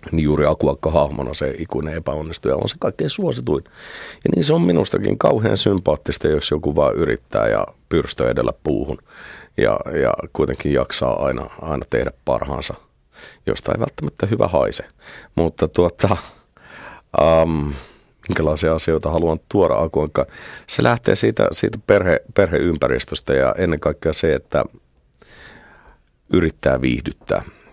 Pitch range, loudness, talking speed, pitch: 75-80 Hz, -19 LUFS, 130 wpm, 80 Hz